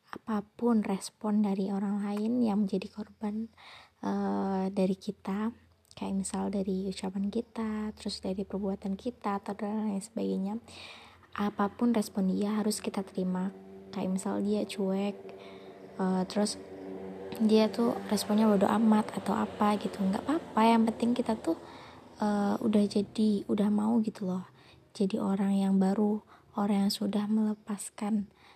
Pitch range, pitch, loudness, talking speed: 195-215 Hz, 205 Hz, -31 LUFS, 135 wpm